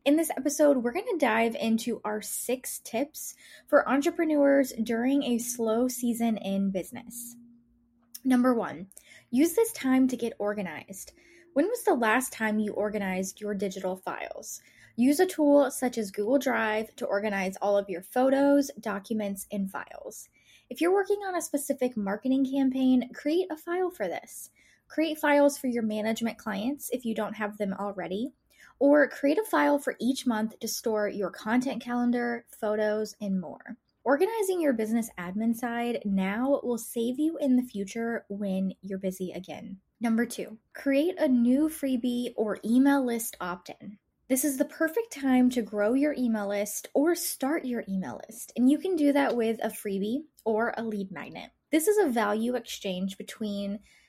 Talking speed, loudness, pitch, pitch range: 170 wpm, -28 LUFS, 240 Hz, 210-280 Hz